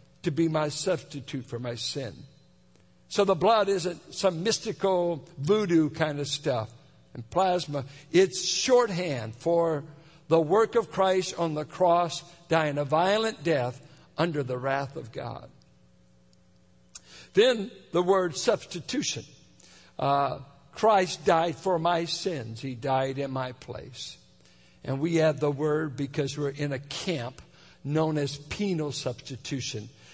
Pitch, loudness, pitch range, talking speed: 150 Hz, -27 LUFS, 135-175 Hz, 135 wpm